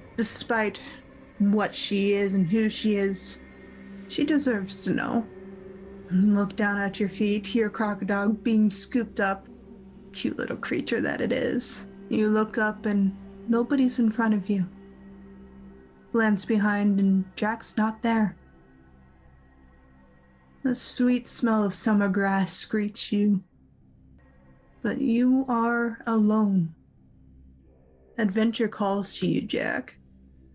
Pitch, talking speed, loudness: 200 Hz, 120 wpm, -26 LUFS